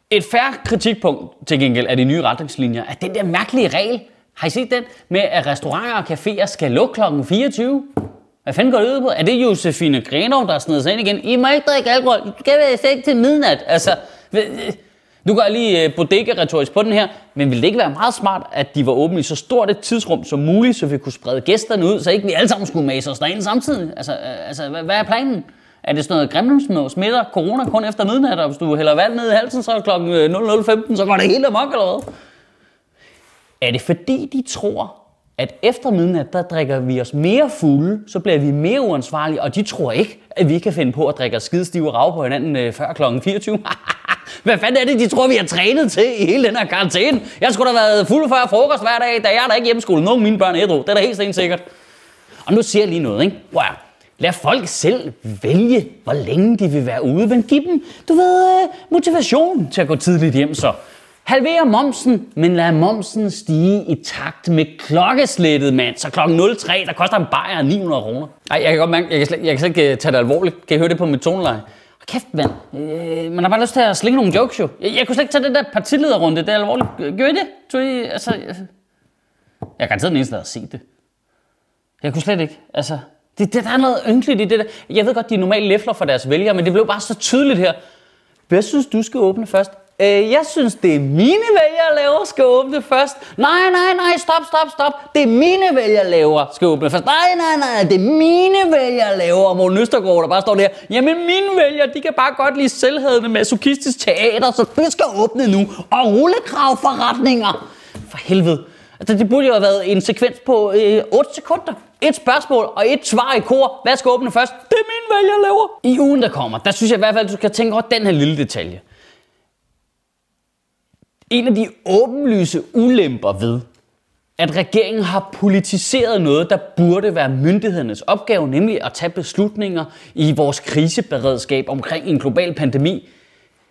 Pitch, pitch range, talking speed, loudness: 210 Hz, 170-255 Hz, 225 wpm, -16 LUFS